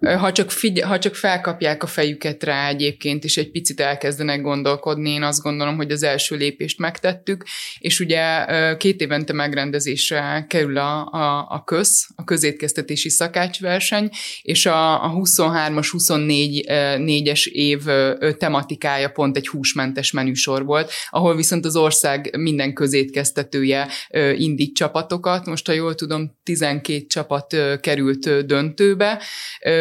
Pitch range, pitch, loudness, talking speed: 145-165 Hz, 150 Hz, -19 LUFS, 130 wpm